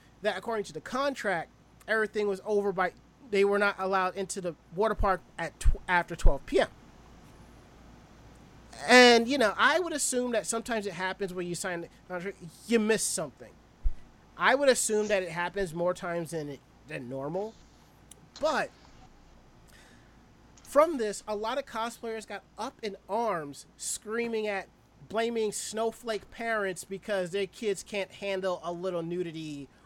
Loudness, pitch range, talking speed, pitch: -29 LUFS, 180-225 Hz, 150 wpm, 200 Hz